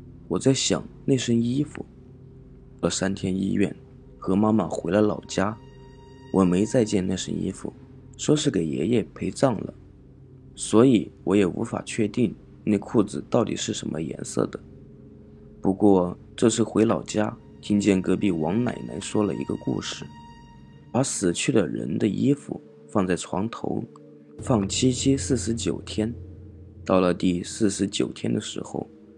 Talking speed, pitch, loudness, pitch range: 210 characters per minute, 100 Hz, -25 LUFS, 90-115 Hz